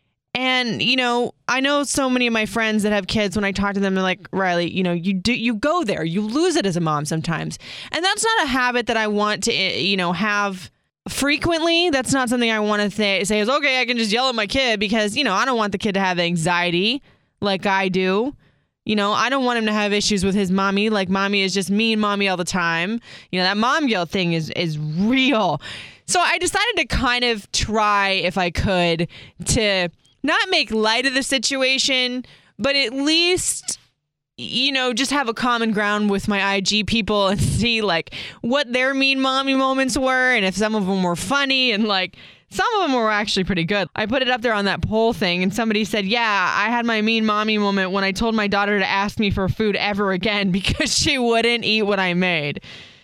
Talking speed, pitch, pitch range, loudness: 230 wpm, 215 Hz, 195-255 Hz, -19 LUFS